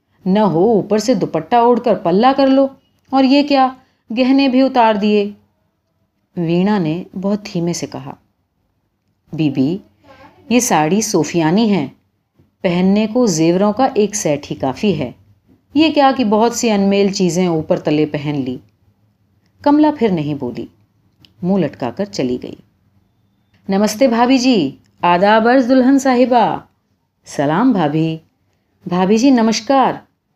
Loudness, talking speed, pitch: -15 LUFS, 135 wpm, 190 Hz